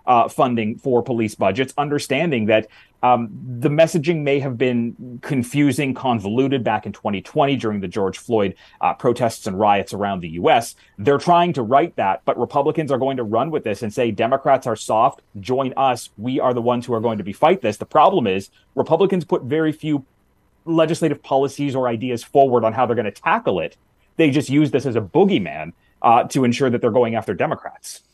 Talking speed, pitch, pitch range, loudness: 200 wpm, 125 Hz, 115-140 Hz, -19 LUFS